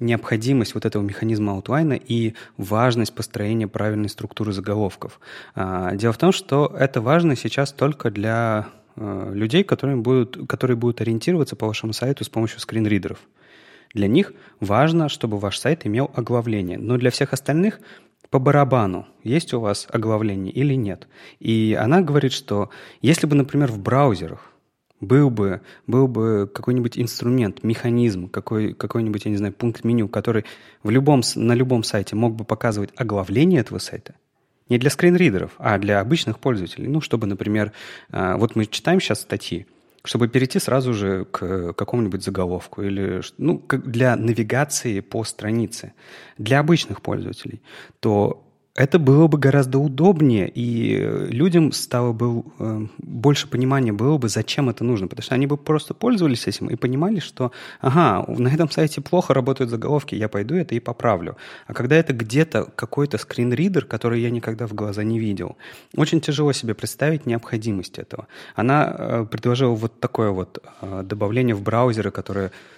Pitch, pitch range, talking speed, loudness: 120 Hz, 105-135 Hz, 155 wpm, -21 LUFS